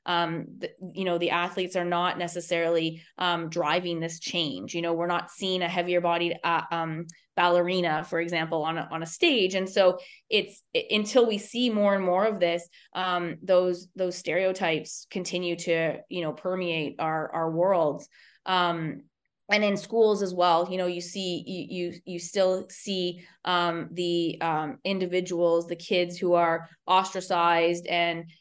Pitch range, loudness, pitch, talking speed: 170-185 Hz, -27 LUFS, 175 Hz, 165 wpm